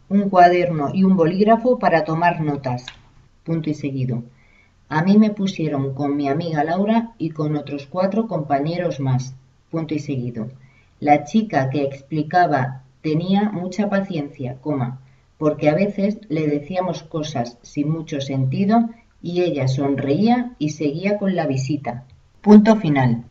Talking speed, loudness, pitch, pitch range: 140 wpm, -20 LUFS, 150 Hz, 135-180 Hz